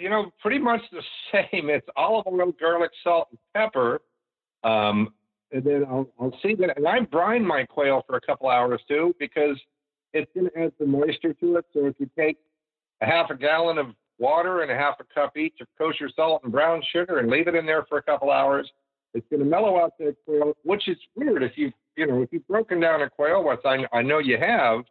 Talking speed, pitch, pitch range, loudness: 230 wpm, 155 Hz, 140-170 Hz, -24 LUFS